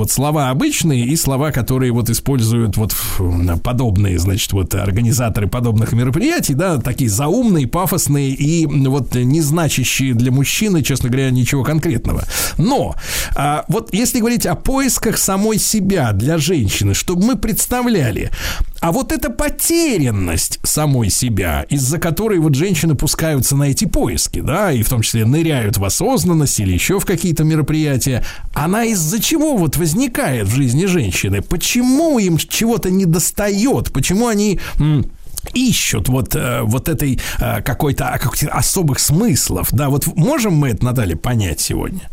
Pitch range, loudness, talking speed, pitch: 120-180 Hz, -16 LUFS, 145 wpm, 140 Hz